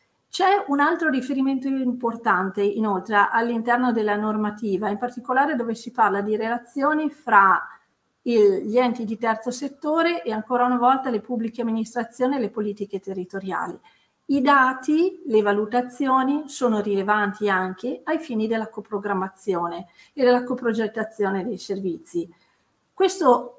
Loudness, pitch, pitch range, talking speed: -23 LUFS, 235 Hz, 205-260 Hz, 130 wpm